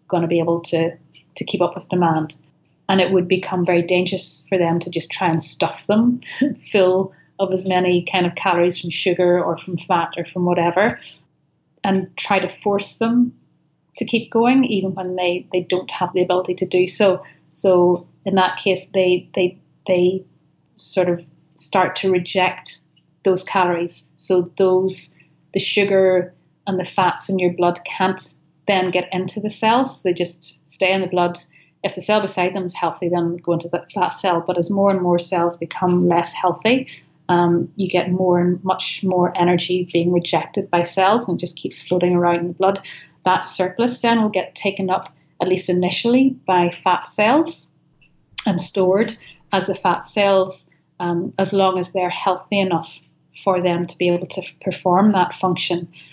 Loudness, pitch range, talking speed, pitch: -19 LUFS, 175-190 Hz, 185 wpm, 180 Hz